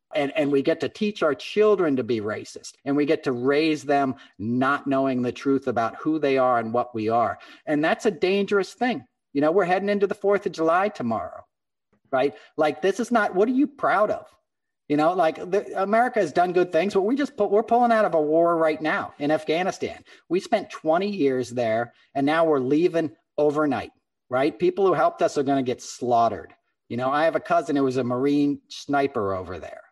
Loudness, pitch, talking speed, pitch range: -23 LUFS, 160 Hz, 220 wpm, 140-205 Hz